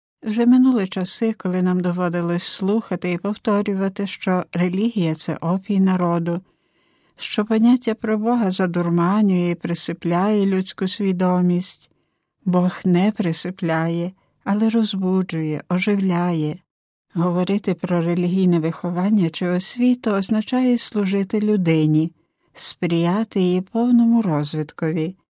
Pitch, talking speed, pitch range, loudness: 185 Hz, 100 wpm, 175-210 Hz, -20 LUFS